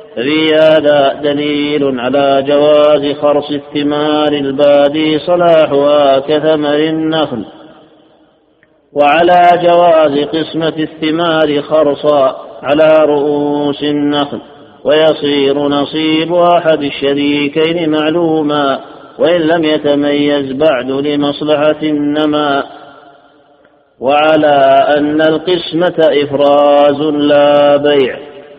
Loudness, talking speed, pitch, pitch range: -11 LUFS, 75 wpm, 150 Hz, 145-155 Hz